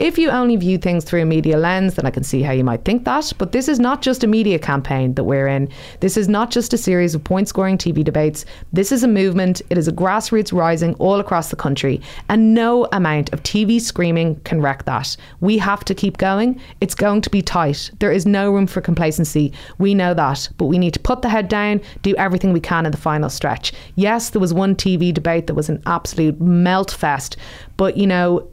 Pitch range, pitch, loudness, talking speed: 160-205 Hz, 185 Hz, -17 LUFS, 235 wpm